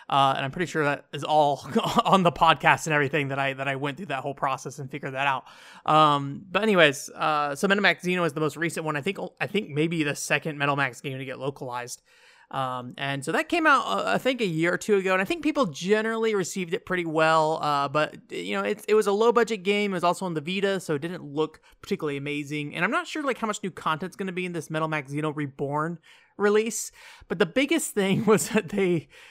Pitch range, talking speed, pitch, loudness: 145-200 Hz, 250 wpm, 160 Hz, -25 LUFS